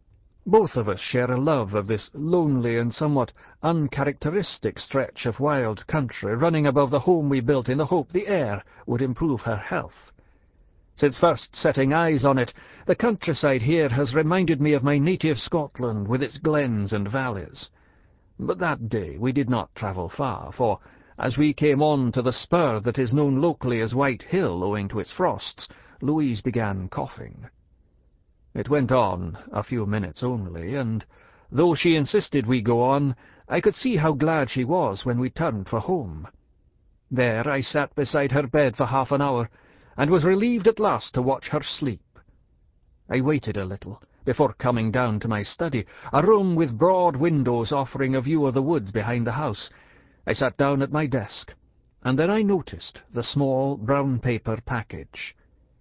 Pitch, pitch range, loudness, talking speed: 135 Hz, 115-150 Hz, -24 LUFS, 175 wpm